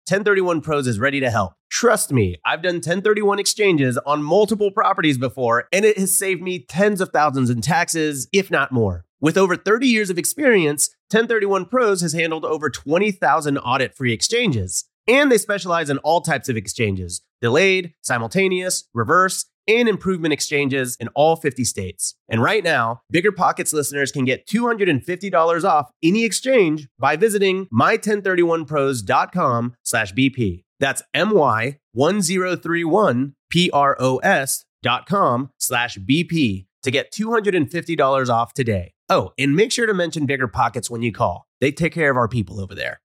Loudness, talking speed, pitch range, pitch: -19 LUFS, 145 wpm, 125-190 Hz, 155 Hz